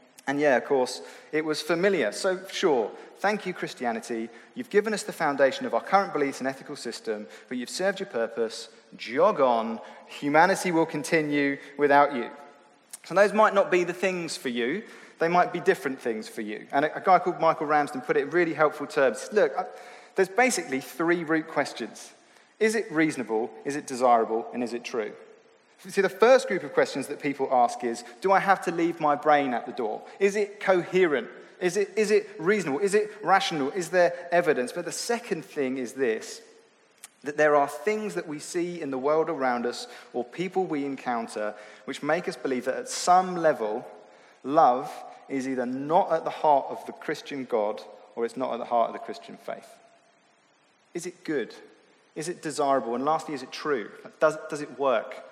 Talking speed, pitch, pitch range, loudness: 195 wpm, 155 Hz, 130-190 Hz, -26 LUFS